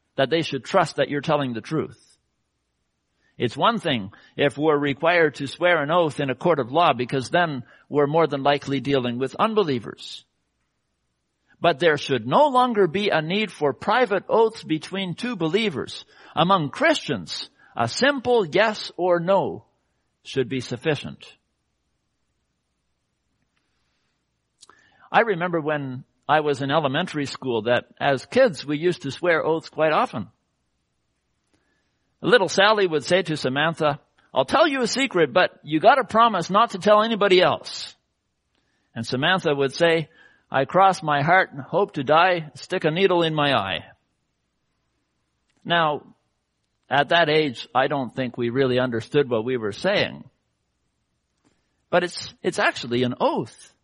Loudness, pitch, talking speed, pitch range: -22 LUFS, 155 Hz, 150 wpm, 135-185 Hz